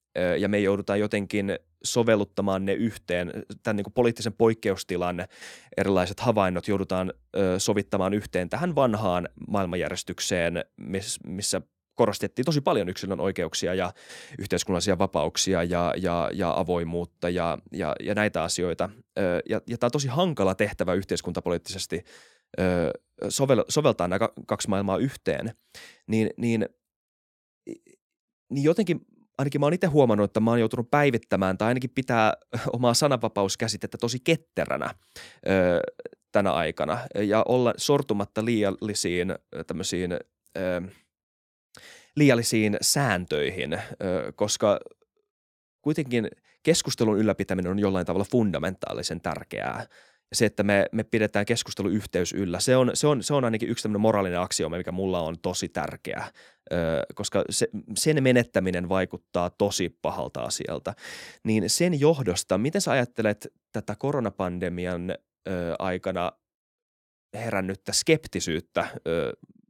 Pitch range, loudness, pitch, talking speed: 95-120 Hz, -26 LUFS, 105 Hz, 115 wpm